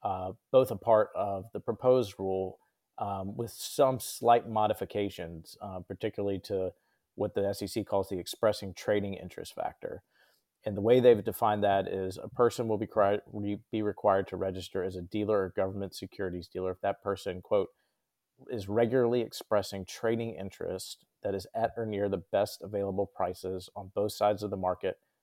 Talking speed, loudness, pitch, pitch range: 170 wpm, -31 LUFS, 100 Hz, 95-110 Hz